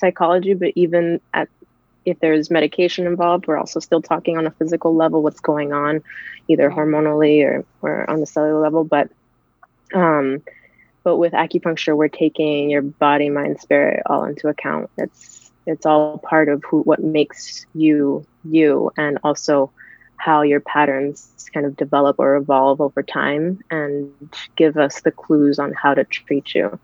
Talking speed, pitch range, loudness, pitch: 165 wpm, 145-160 Hz, -18 LUFS, 155 Hz